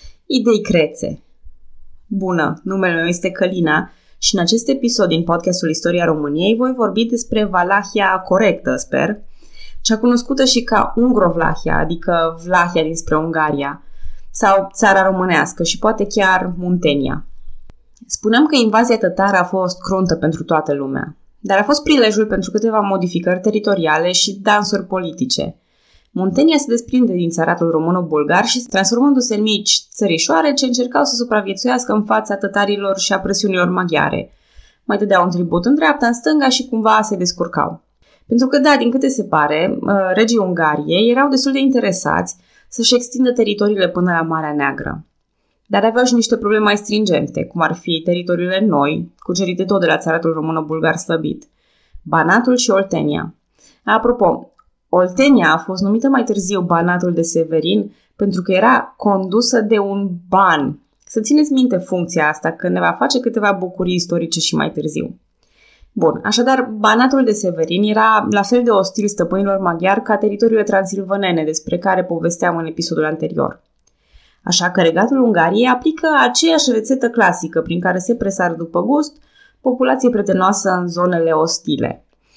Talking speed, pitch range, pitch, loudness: 150 wpm, 170-230 Hz, 195 Hz, -15 LUFS